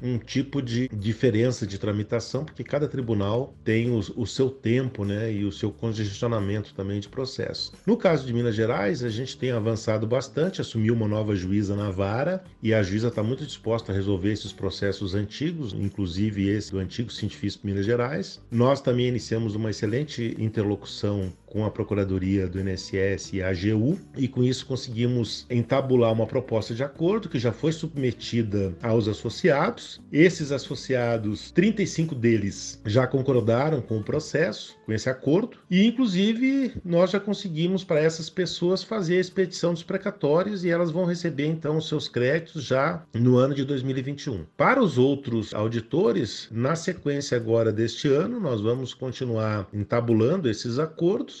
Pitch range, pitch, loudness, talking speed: 110-150 Hz, 120 Hz, -26 LUFS, 160 wpm